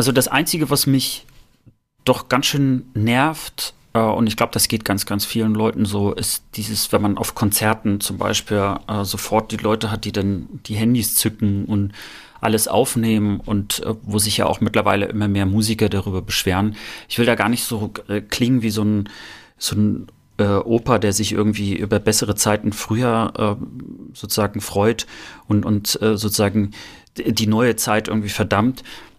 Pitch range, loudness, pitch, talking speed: 105-115 Hz, -19 LUFS, 110 Hz, 175 wpm